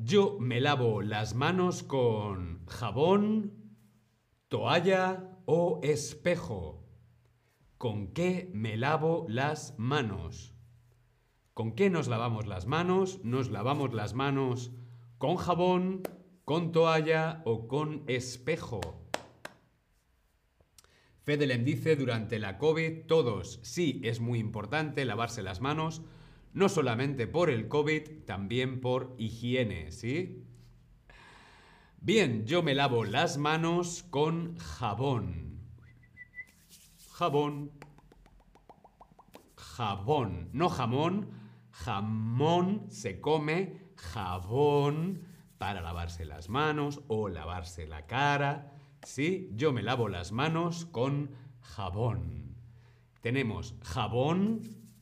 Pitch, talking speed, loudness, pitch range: 130 Hz, 95 wpm, -31 LUFS, 115-160 Hz